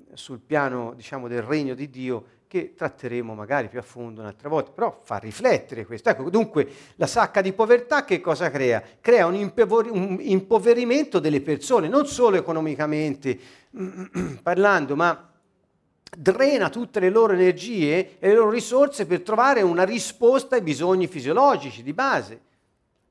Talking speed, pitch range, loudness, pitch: 145 wpm, 140-225 Hz, -22 LUFS, 180 Hz